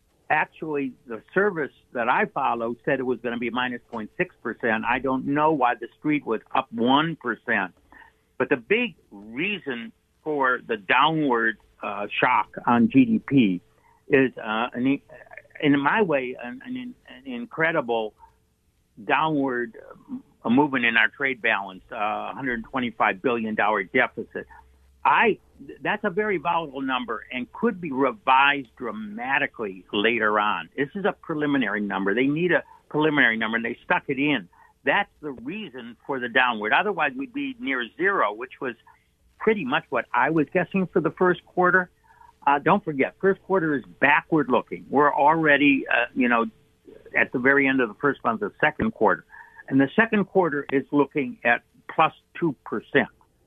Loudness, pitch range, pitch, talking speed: -23 LUFS, 120-180 Hz, 140 Hz, 155 wpm